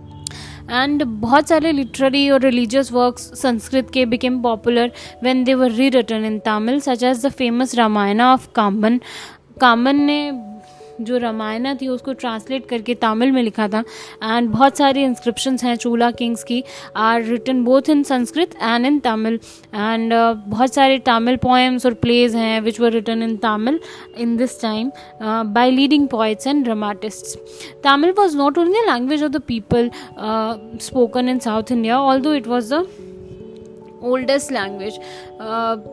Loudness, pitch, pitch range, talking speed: -17 LUFS, 245 Hz, 225-265 Hz, 150 wpm